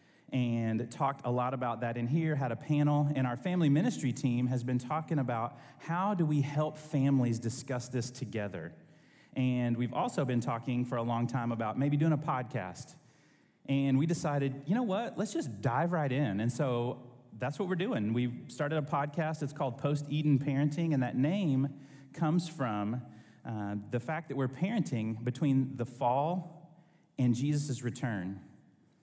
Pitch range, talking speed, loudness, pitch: 120-150 Hz, 175 wpm, -33 LUFS, 135 Hz